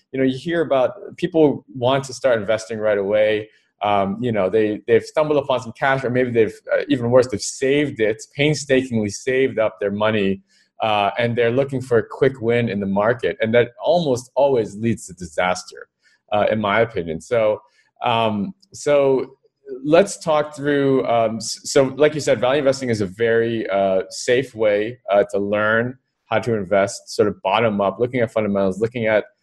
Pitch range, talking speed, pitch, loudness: 105-140 Hz, 185 wpm, 120 Hz, -20 LUFS